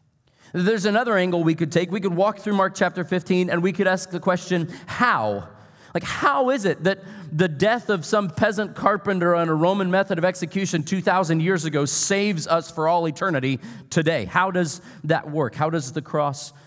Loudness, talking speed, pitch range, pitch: -22 LUFS, 195 wpm, 165-195 Hz, 180 Hz